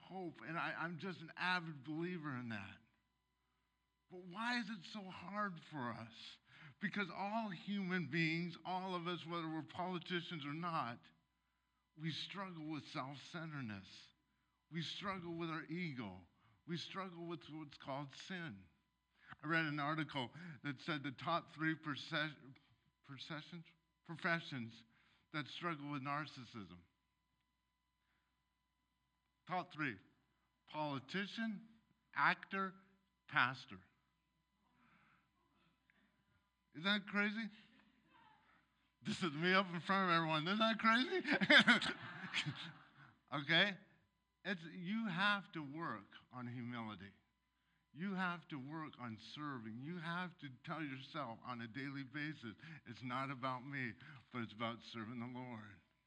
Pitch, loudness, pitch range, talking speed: 155 Hz, -42 LUFS, 125-180 Hz, 120 wpm